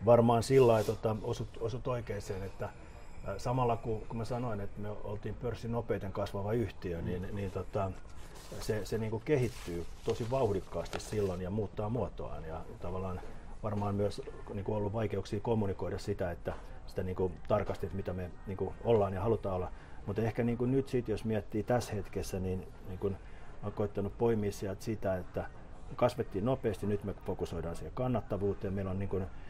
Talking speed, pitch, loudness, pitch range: 180 wpm, 100 Hz, -35 LUFS, 95-115 Hz